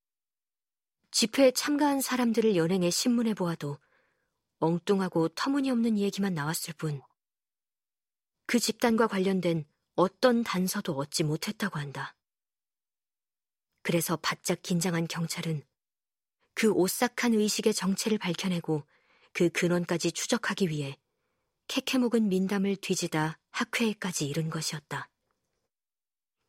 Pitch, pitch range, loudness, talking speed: 185 Hz, 165-225 Hz, -29 LUFS, 255 characters per minute